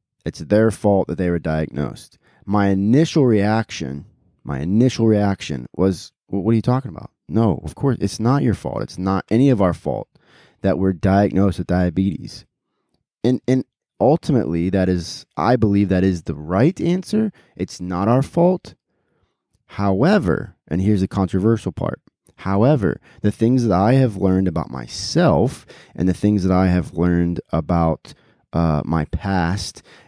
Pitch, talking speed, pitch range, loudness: 95 Hz, 160 wpm, 90-115 Hz, -19 LUFS